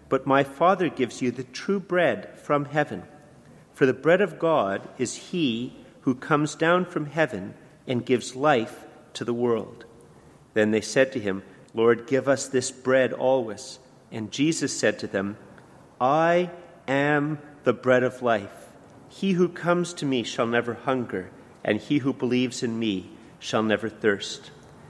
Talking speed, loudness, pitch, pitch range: 160 wpm, -25 LUFS, 130 Hz, 120-150 Hz